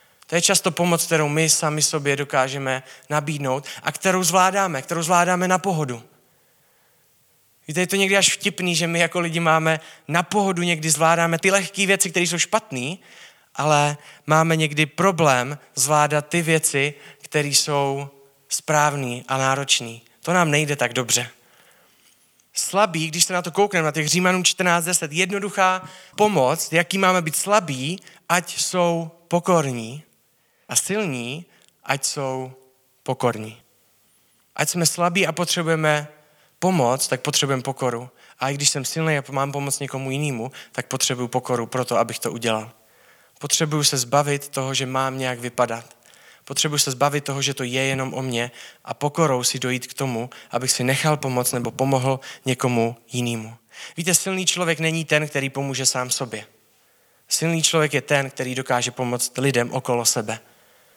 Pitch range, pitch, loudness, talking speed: 130-170 Hz, 145 Hz, -21 LUFS, 155 wpm